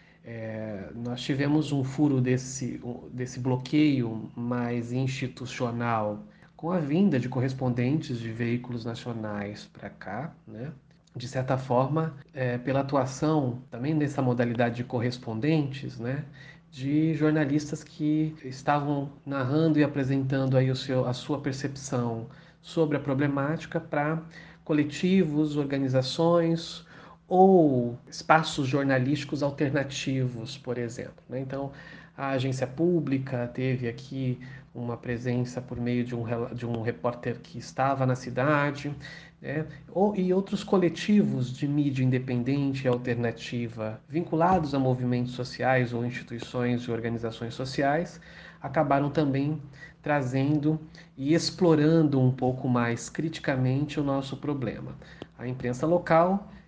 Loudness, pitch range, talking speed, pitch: -28 LUFS, 125-155 Hz, 115 wpm, 135 Hz